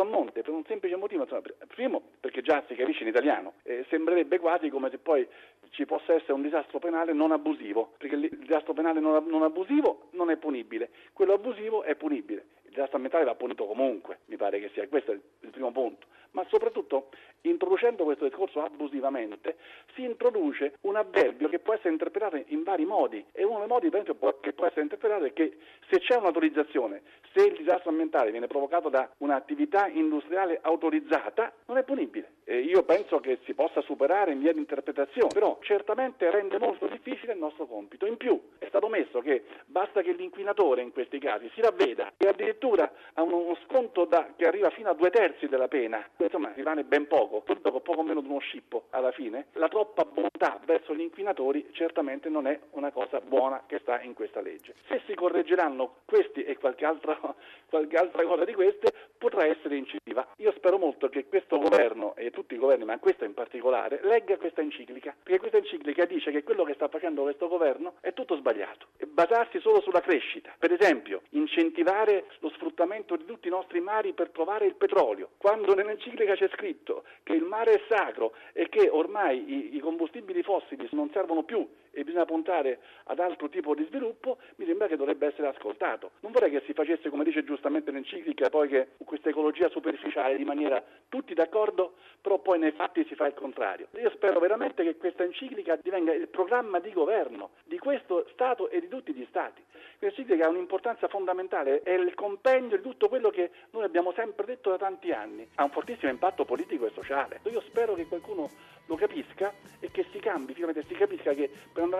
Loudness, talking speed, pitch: -29 LUFS, 190 wpm, 195 Hz